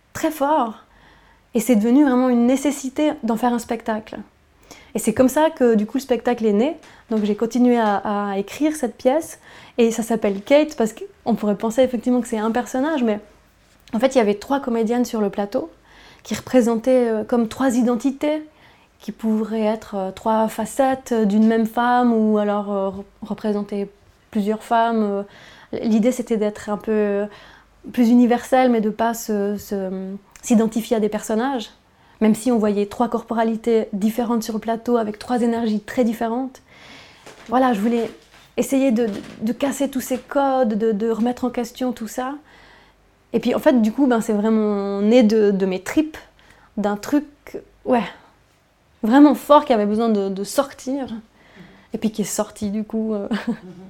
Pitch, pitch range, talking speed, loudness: 230 Hz, 215-250 Hz, 175 wpm, -20 LUFS